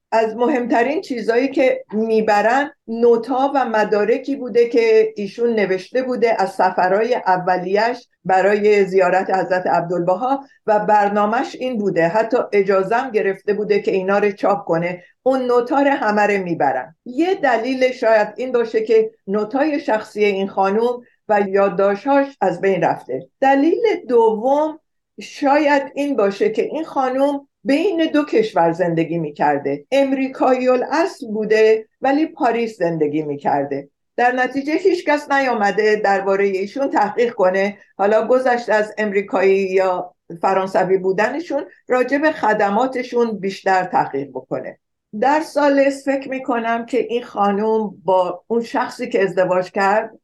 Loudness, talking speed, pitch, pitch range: -18 LUFS, 125 wpm, 220 Hz, 195-265 Hz